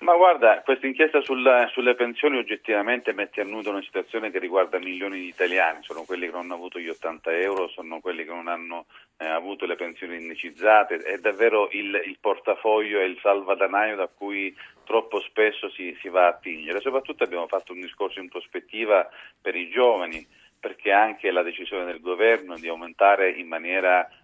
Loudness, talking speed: -24 LUFS, 180 wpm